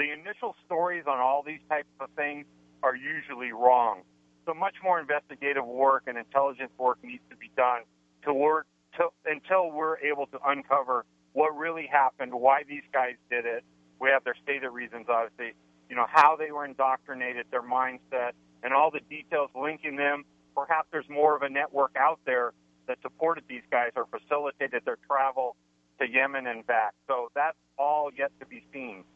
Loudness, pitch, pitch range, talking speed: -28 LUFS, 140 Hz, 120-150 Hz, 180 wpm